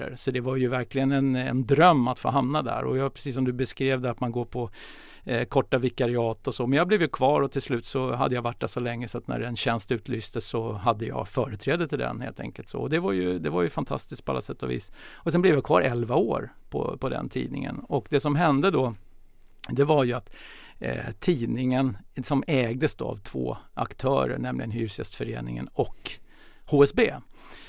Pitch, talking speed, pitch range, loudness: 125 Hz, 220 wpm, 115-135 Hz, -27 LUFS